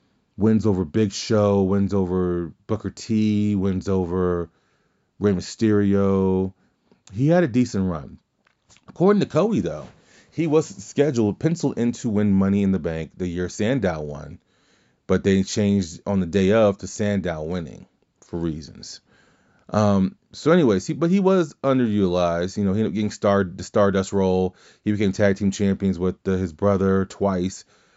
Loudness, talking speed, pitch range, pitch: -22 LUFS, 165 wpm, 95-105 Hz, 100 Hz